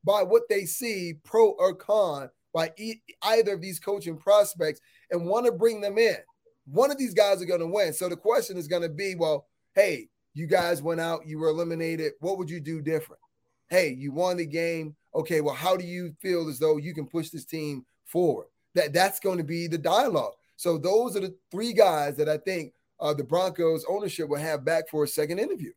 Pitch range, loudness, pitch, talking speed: 160-200 Hz, -27 LUFS, 175 Hz, 220 wpm